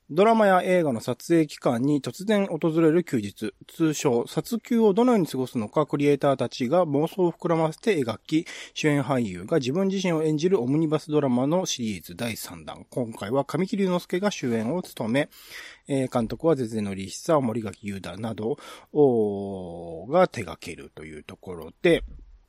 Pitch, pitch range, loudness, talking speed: 145 Hz, 115-170 Hz, -25 LUFS, 330 characters per minute